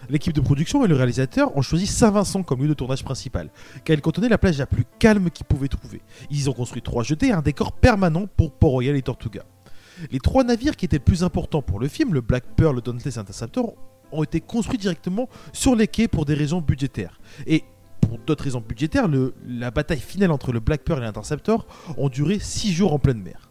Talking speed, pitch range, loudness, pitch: 230 wpm, 125-180 Hz, -22 LUFS, 145 Hz